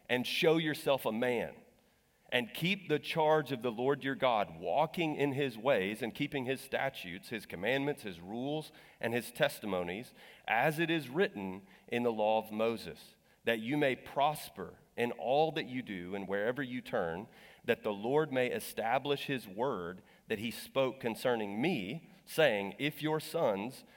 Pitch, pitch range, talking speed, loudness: 135 Hz, 115-155 Hz, 170 wpm, -34 LUFS